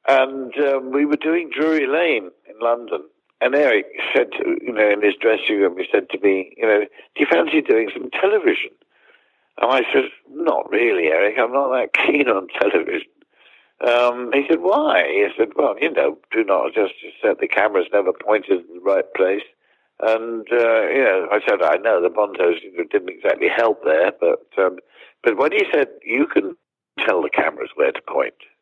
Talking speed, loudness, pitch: 195 wpm, -19 LUFS, 390 Hz